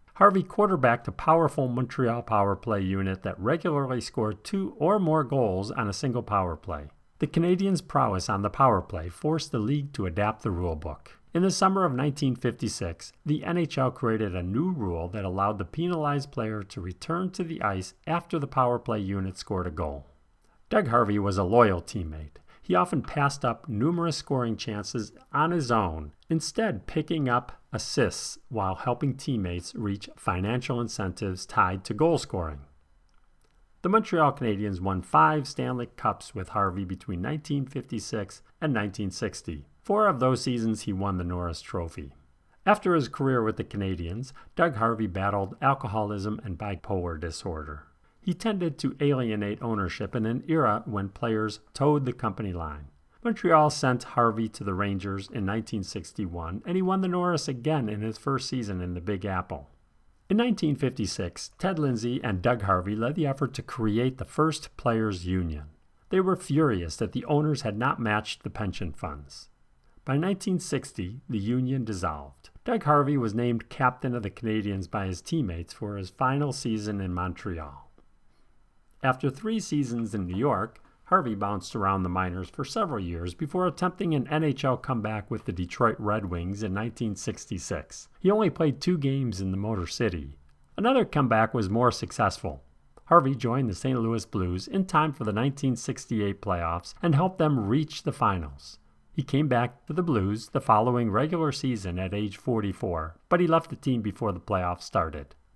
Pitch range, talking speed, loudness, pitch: 95-140 Hz, 165 wpm, -28 LUFS, 115 Hz